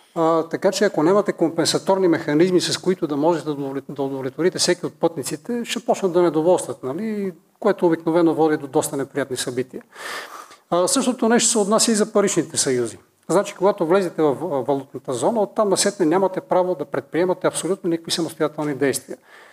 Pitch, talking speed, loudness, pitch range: 170 Hz, 160 wpm, -20 LUFS, 145-190 Hz